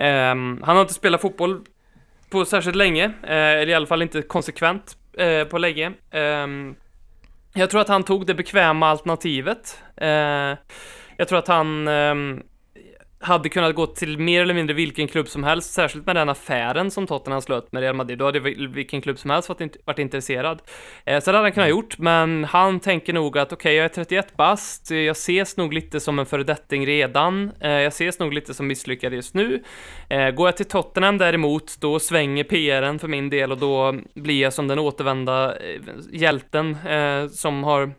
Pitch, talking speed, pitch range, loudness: 155 Hz, 190 wpm, 140-175 Hz, -21 LUFS